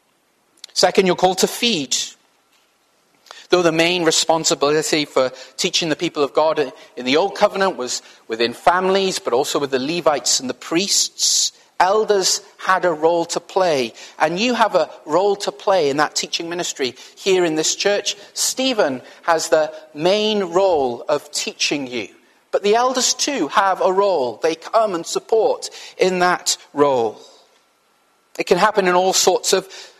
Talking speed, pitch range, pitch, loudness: 160 wpm, 160-210 Hz, 185 Hz, -18 LUFS